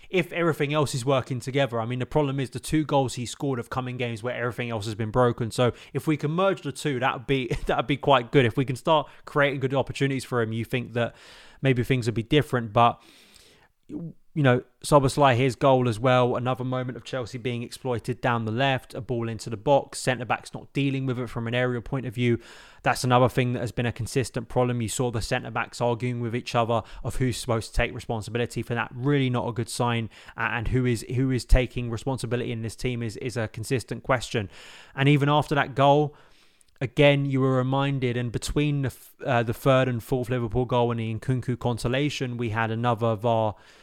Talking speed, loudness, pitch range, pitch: 220 wpm, -25 LUFS, 120-135 Hz, 125 Hz